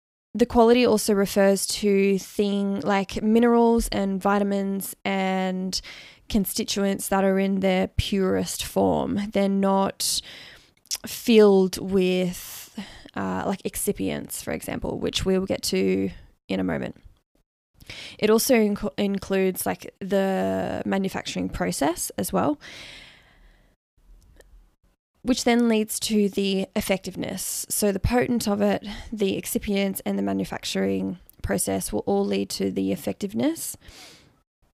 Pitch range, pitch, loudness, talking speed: 175-210 Hz, 195 Hz, -24 LUFS, 115 wpm